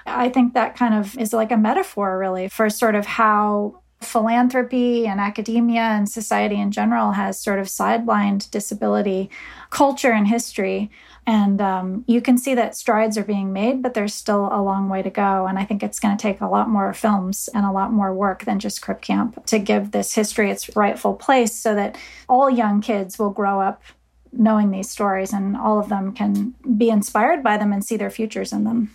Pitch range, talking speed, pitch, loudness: 200-230 Hz, 205 wpm, 210 Hz, -20 LUFS